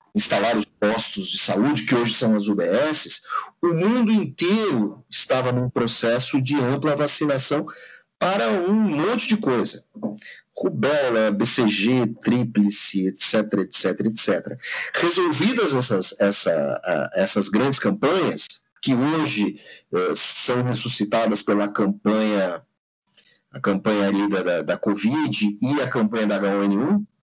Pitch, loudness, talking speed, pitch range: 115 Hz, -22 LUFS, 115 wpm, 105-145 Hz